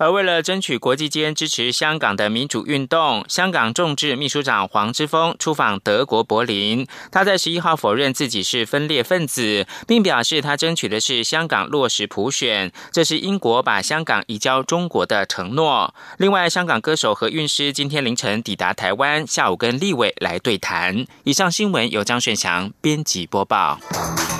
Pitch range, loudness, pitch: 120-170 Hz, -19 LUFS, 145 Hz